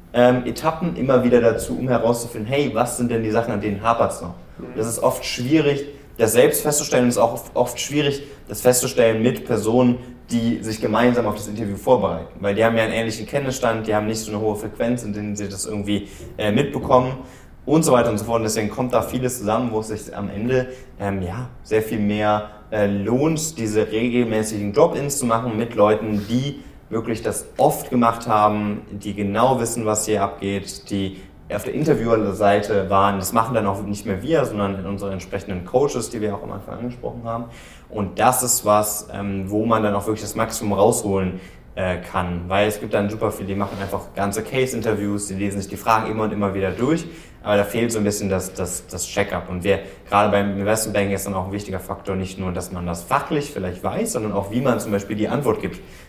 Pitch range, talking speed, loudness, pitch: 100-120 Hz, 215 wpm, -21 LUFS, 105 Hz